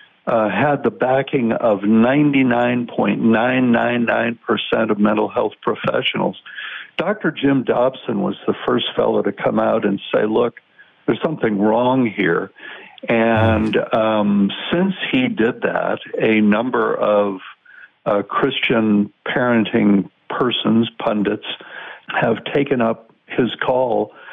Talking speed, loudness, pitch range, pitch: 115 wpm, -18 LUFS, 105-130 Hz, 115 Hz